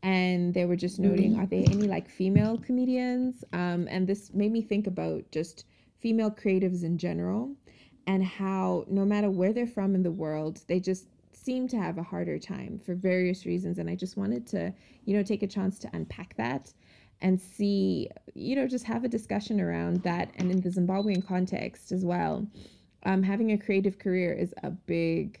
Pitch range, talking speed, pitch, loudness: 180-210 Hz, 195 wpm, 195 Hz, -29 LUFS